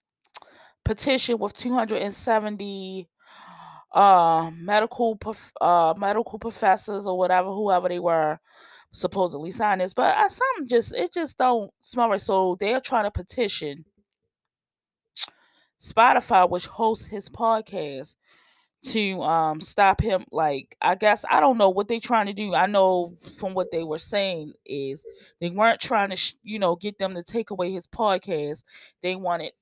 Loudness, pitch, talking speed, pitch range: -23 LUFS, 200 Hz, 160 wpm, 180-225 Hz